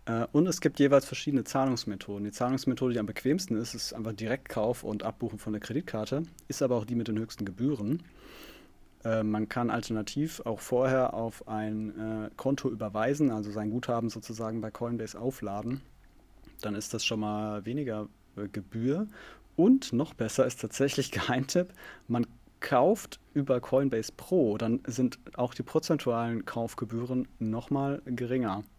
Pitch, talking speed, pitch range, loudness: 120 Hz, 150 wpm, 110-135 Hz, -31 LUFS